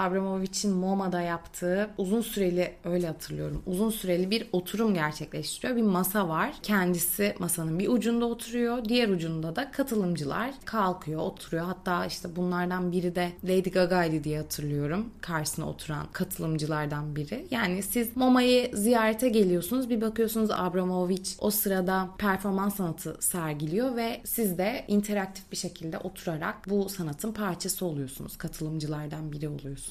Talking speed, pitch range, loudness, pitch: 130 wpm, 170-215 Hz, -29 LUFS, 185 Hz